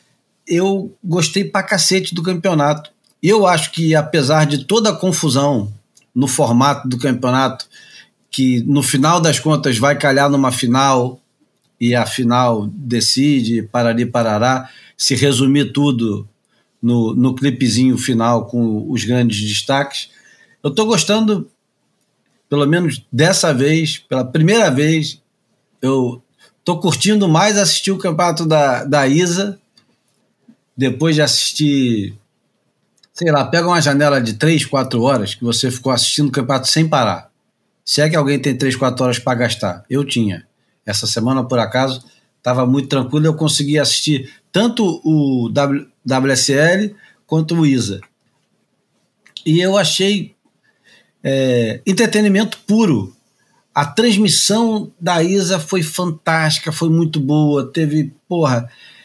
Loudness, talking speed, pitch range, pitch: -15 LUFS, 130 wpm, 125-170 Hz, 145 Hz